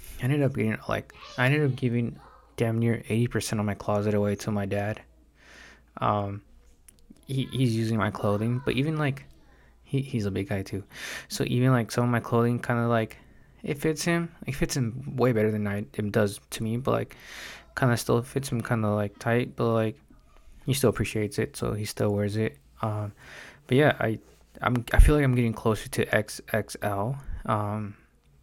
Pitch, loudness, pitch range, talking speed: 115 Hz, -27 LUFS, 105-125 Hz, 200 wpm